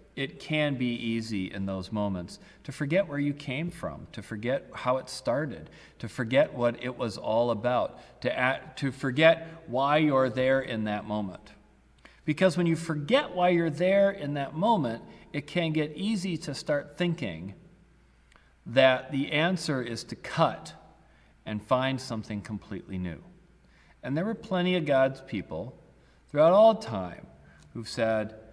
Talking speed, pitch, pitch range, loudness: 160 wpm, 130 Hz, 110-160 Hz, -28 LUFS